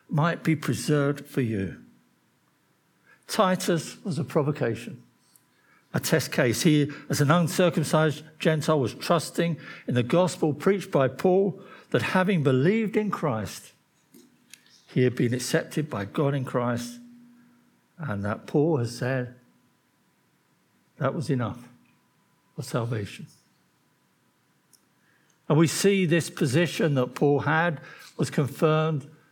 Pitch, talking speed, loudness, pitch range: 155 Hz, 120 wpm, -25 LUFS, 135-175 Hz